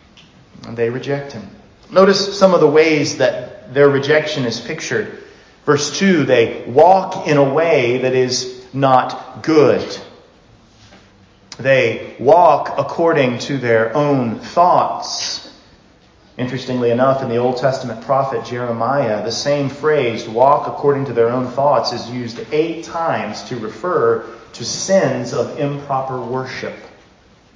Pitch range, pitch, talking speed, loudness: 120-145 Hz, 130 Hz, 130 wpm, -16 LUFS